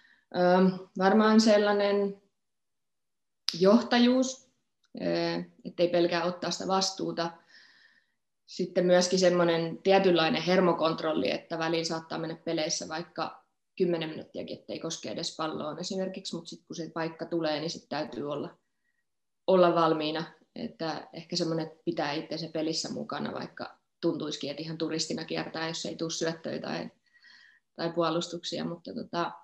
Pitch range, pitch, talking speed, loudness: 160-190 Hz, 170 Hz, 120 wpm, -29 LUFS